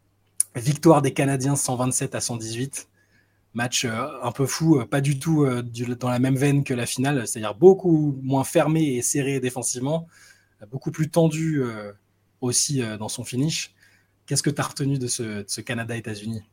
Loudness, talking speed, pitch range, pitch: -23 LUFS, 155 wpm, 110-145 Hz, 125 Hz